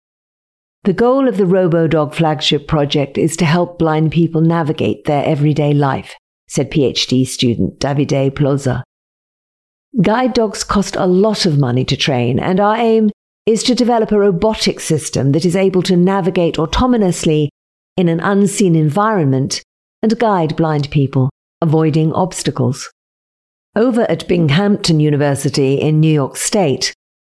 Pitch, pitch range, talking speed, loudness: 160 Hz, 145-195 Hz, 140 wpm, -14 LUFS